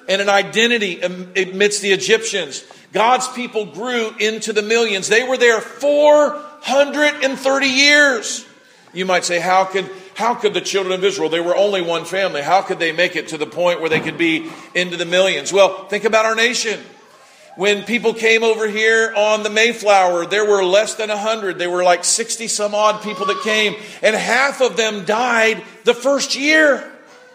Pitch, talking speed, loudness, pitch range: 210 Hz, 180 wpm, -16 LUFS, 190-230 Hz